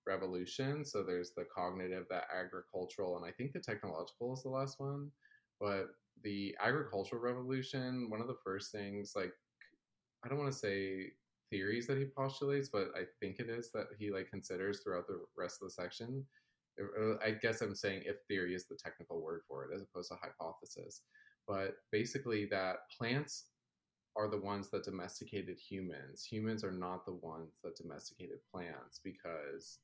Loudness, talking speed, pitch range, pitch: -42 LUFS, 170 wpm, 95-135 Hz, 110 Hz